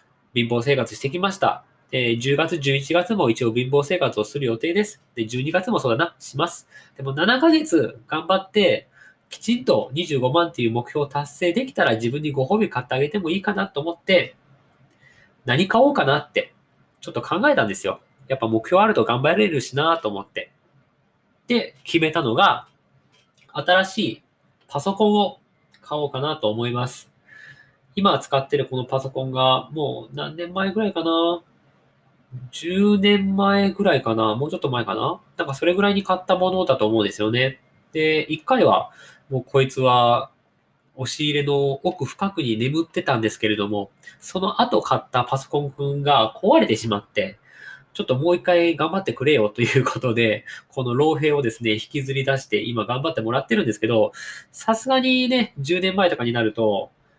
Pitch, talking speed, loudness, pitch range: 140 Hz, 335 characters per minute, -21 LUFS, 125-175 Hz